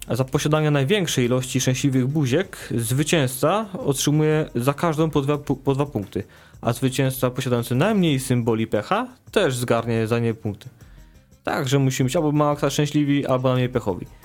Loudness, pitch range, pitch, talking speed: -22 LUFS, 120-150 Hz, 130 Hz, 145 wpm